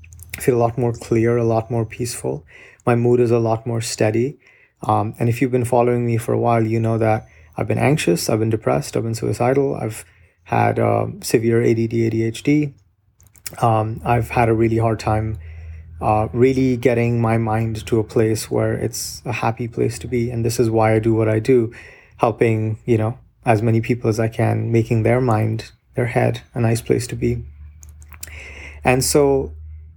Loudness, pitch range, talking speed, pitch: -19 LUFS, 110-120 Hz, 190 wpm, 115 Hz